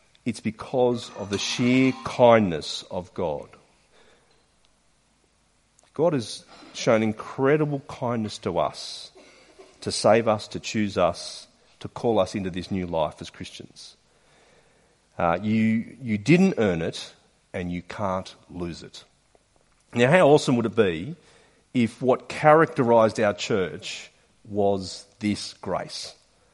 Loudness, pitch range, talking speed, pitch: -24 LUFS, 100-125 Hz, 125 wpm, 110 Hz